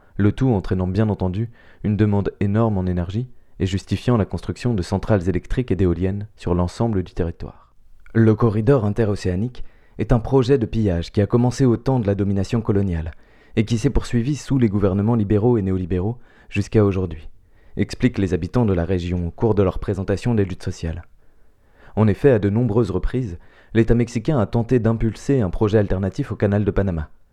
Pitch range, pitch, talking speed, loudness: 95-115 Hz, 105 Hz, 185 wpm, -21 LUFS